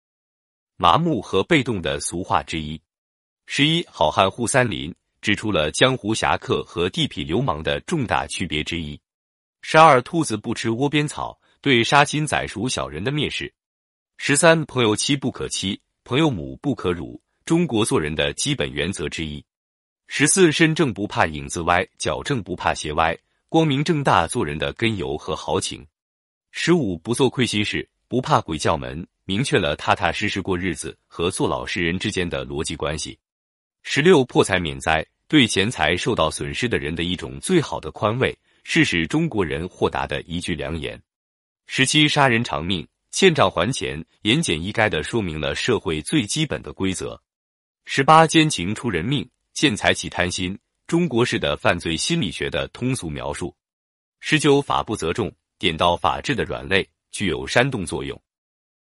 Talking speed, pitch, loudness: 250 characters per minute, 110 Hz, -21 LUFS